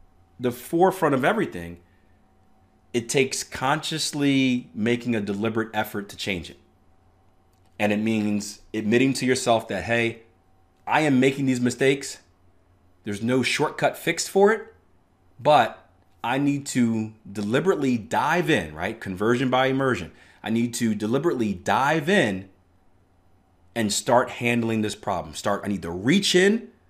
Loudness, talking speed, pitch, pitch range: -23 LUFS, 135 wpm, 110 Hz, 95-130 Hz